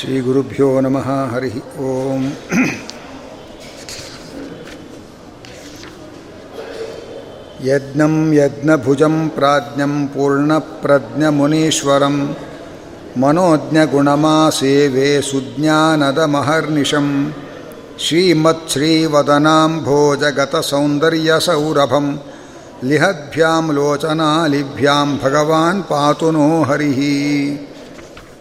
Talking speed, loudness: 40 wpm, -15 LUFS